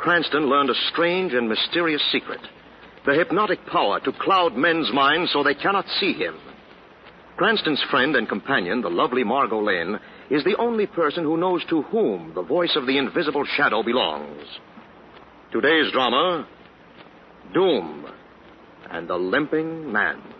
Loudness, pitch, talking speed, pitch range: -21 LUFS, 160 Hz, 145 wpm, 140-175 Hz